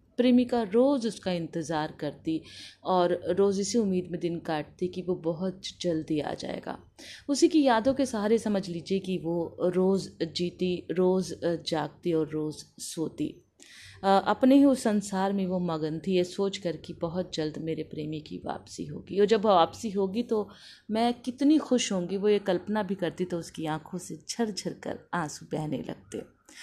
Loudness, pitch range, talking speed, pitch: -28 LUFS, 165-210 Hz, 170 wpm, 185 Hz